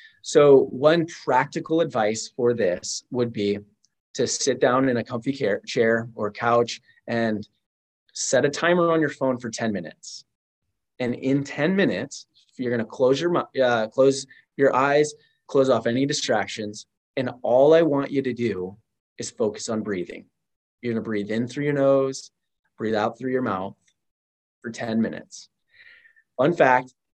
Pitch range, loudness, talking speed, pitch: 110-140 Hz, -23 LUFS, 155 wpm, 125 Hz